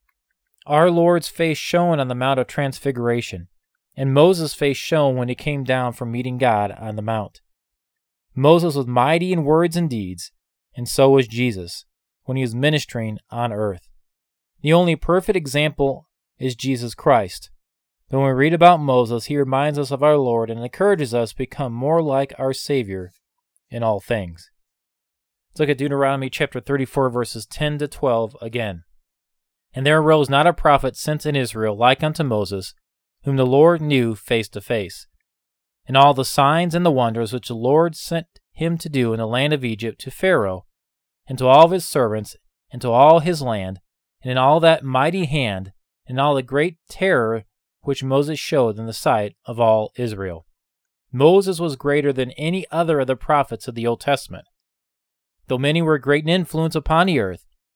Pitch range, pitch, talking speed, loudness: 115-155 Hz, 135 Hz, 180 wpm, -19 LUFS